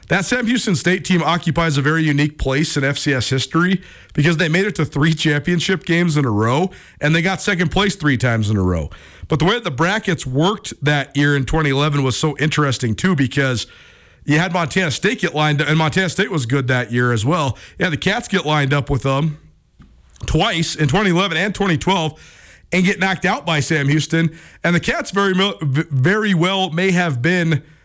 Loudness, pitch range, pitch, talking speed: -17 LUFS, 145-185 Hz, 160 Hz, 205 wpm